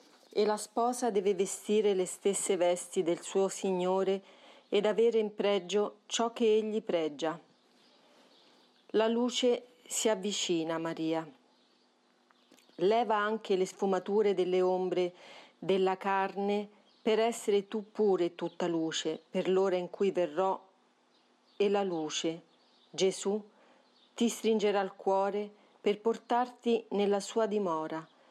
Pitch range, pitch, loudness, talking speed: 185-220 Hz, 200 Hz, -31 LUFS, 120 wpm